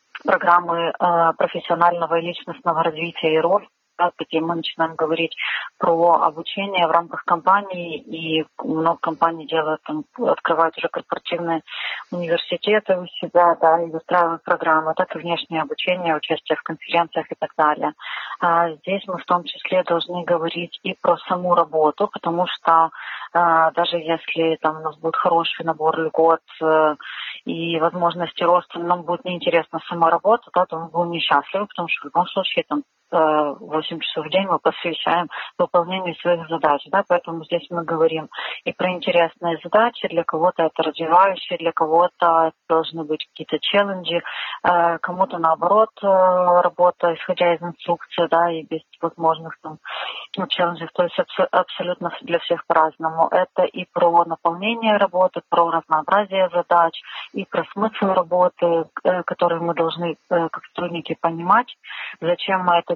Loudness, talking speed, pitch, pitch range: -20 LUFS, 145 wpm, 170 Hz, 165-175 Hz